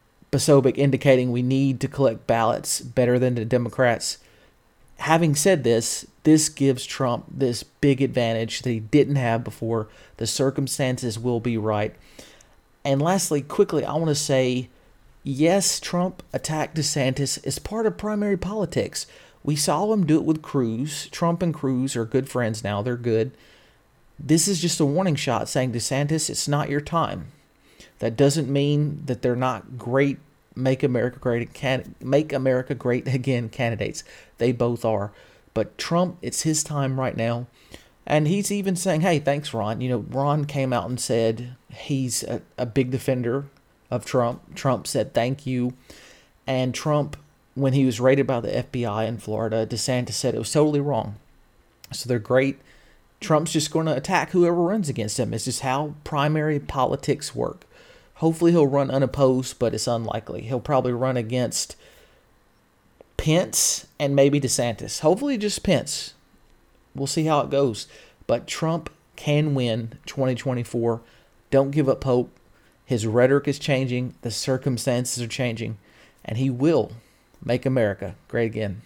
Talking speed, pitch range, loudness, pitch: 160 wpm, 120-150 Hz, -23 LUFS, 130 Hz